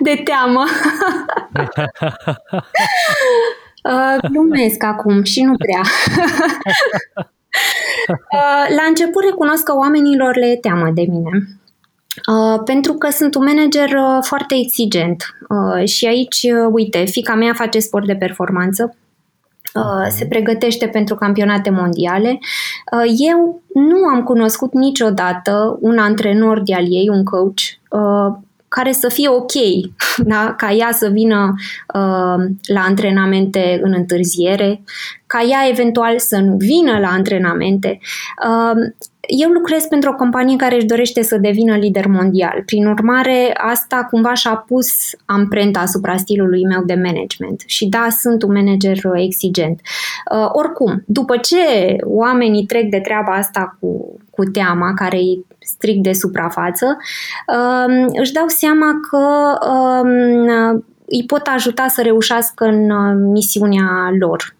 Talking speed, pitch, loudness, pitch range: 130 wpm, 225 Hz, -14 LUFS, 195-260 Hz